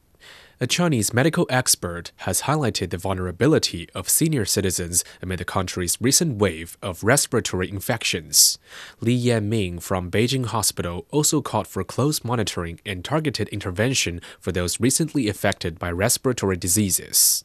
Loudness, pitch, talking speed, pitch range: -22 LUFS, 105 Hz, 135 wpm, 90-130 Hz